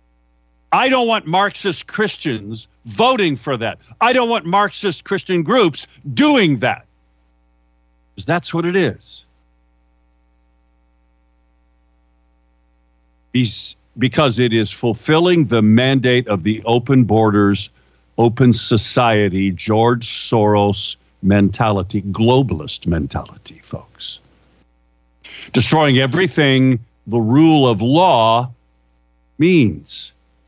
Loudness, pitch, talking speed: -15 LUFS, 110 Hz, 90 wpm